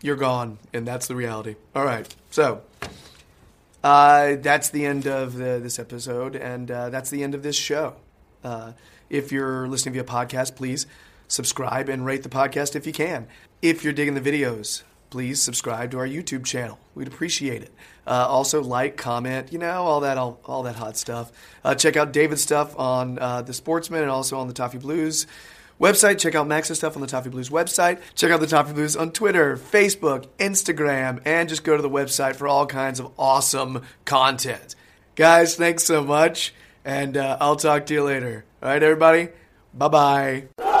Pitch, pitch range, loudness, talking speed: 135 Hz, 125-150 Hz, -22 LUFS, 190 wpm